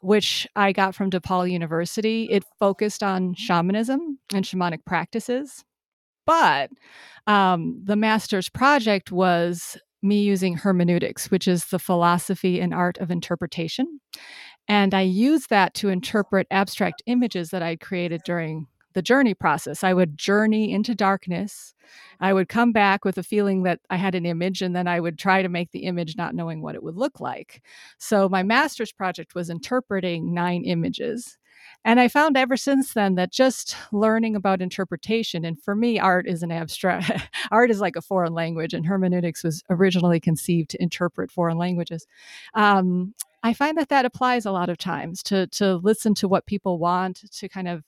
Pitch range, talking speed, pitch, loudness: 175-220 Hz, 175 wpm, 190 Hz, -22 LUFS